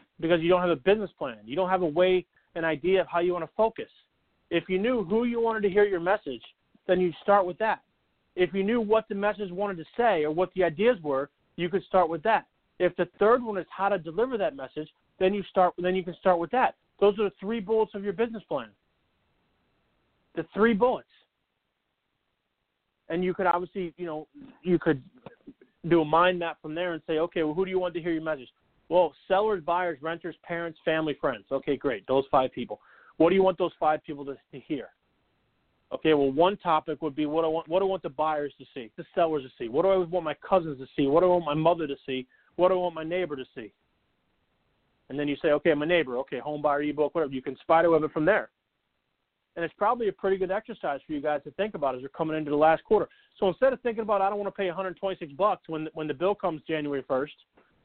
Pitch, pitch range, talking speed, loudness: 175 Hz, 155-195 Hz, 250 wpm, -27 LUFS